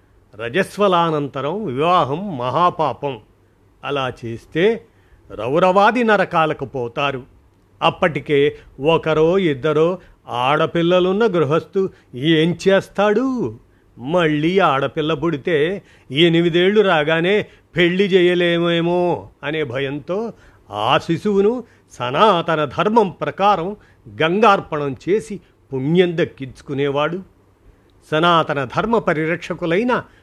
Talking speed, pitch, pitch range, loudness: 70 wpm, 160 Hz, 135-180 Hz, -18 LUFS